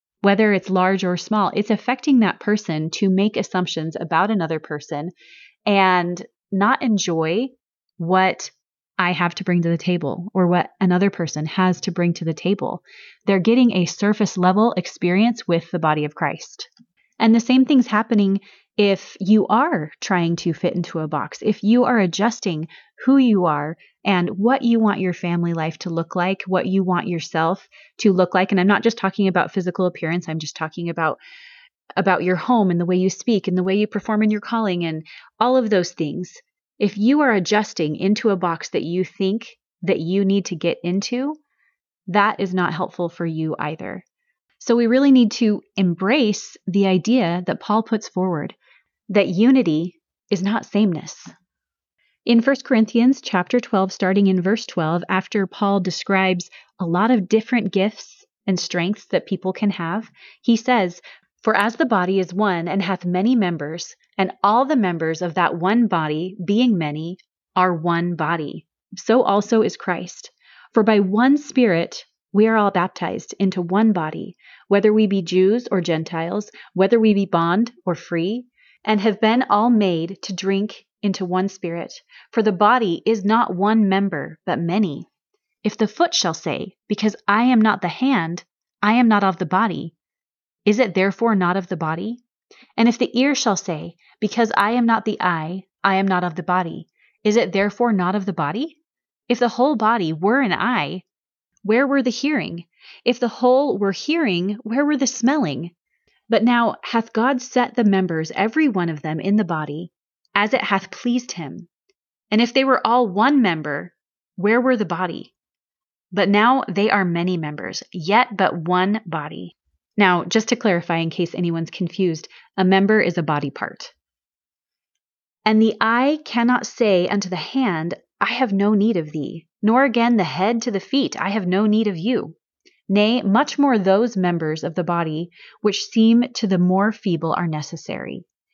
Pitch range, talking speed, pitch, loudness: 175-230 Hz, 180 wpm, 195 Hz, -20 LUFS